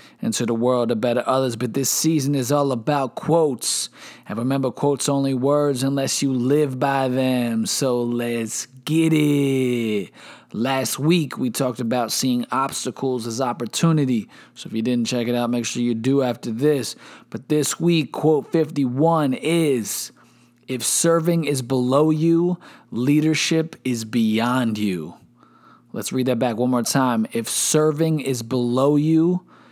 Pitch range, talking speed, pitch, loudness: 120-150 Hz, 155 wpm, 130 Hz, -21 LUFS